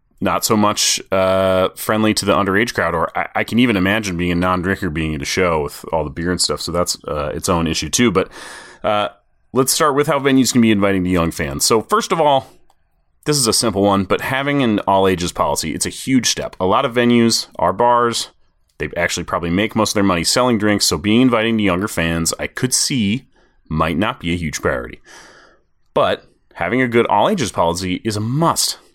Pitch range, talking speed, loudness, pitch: 90-115 Hz, 225 wpm, -17 LUFS, 100 Hz